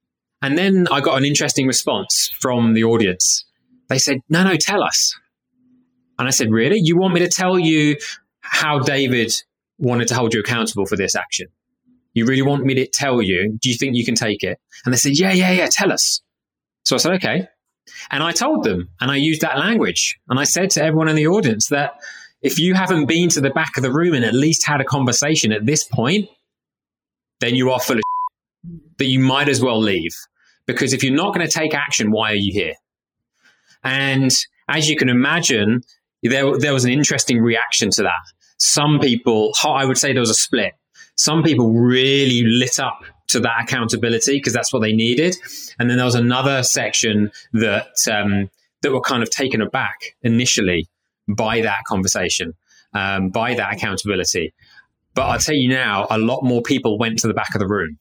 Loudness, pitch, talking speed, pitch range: -17 LUFS, 130 Hz, 200 wpm, 115-150 Hz